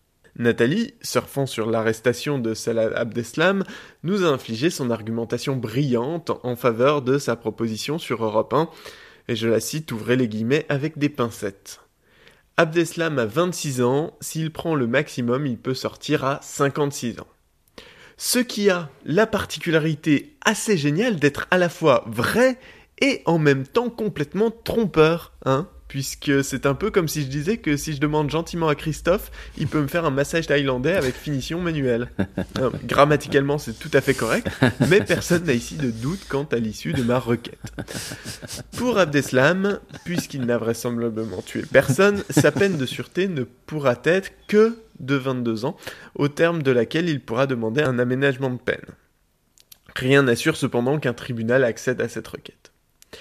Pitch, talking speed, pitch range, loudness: 140 Hz, 165 wpm, 125-165 Hz, -22 LUFS